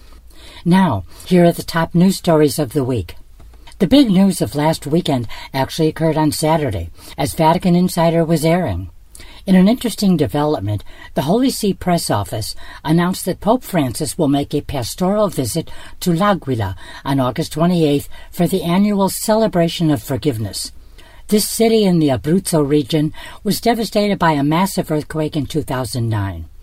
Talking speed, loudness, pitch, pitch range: 155 wpm, -17 LUFS, 160 Hz, 135-180 Hz